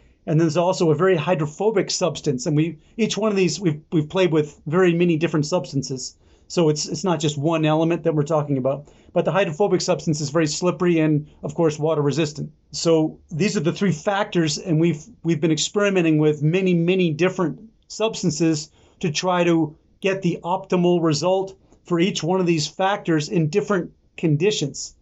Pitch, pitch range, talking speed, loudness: 170 Hz, 155-185 Hz, 185 wpm, -21 LUFS